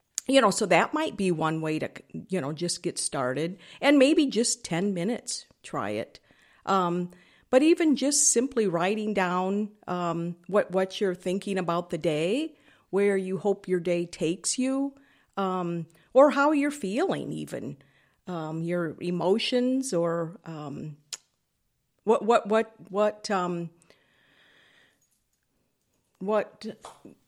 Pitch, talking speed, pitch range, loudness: 190 Hz, 130 wpm, 170-230 Hz, -26 LUFS